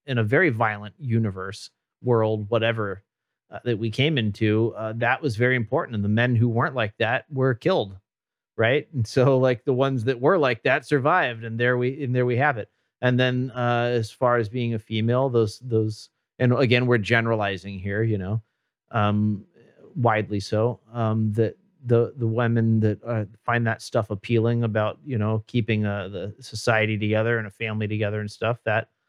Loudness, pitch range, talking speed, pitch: -23 LUFS, 110-125 Hz, 190 wpm, 115 Hz